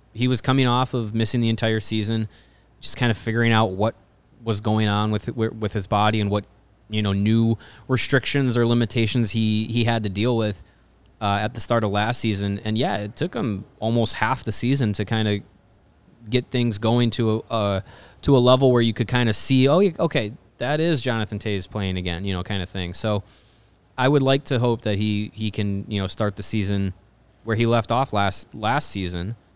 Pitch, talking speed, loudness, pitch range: 110 Hz, 215 wpm, -22 LUFS, 105-120 Hz